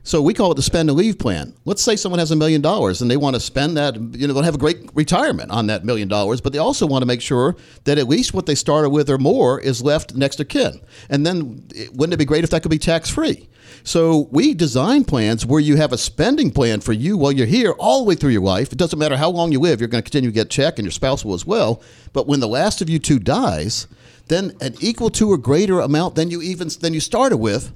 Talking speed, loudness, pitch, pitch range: 280 wpm, -18 LUFS, 145 Hz, 125-165 Hz